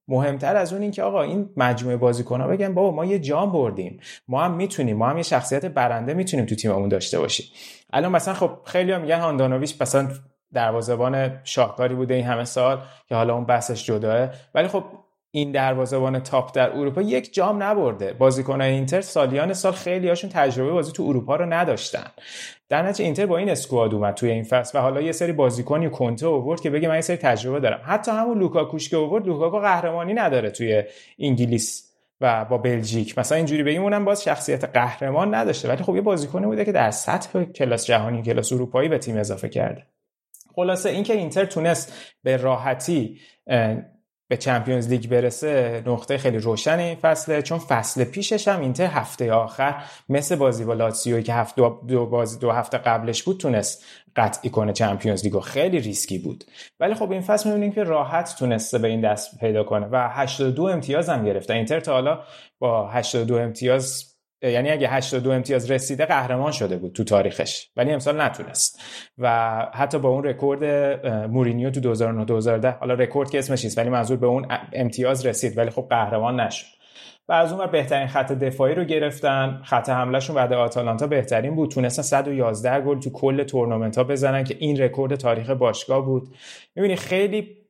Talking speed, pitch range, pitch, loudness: 180 wpm, 120-160 Hz, 130 Hz, -22 LUFS